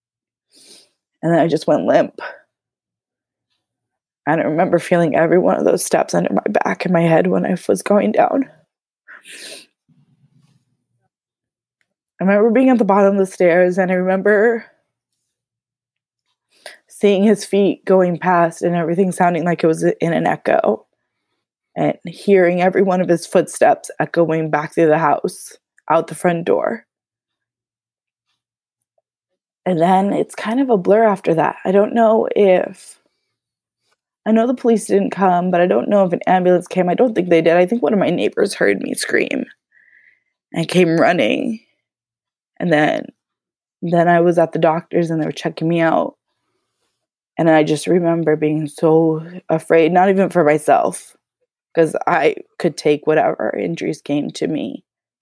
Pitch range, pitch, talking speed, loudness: 160-195 Hz, 175 Hz, 160 wpm, -16 LUFS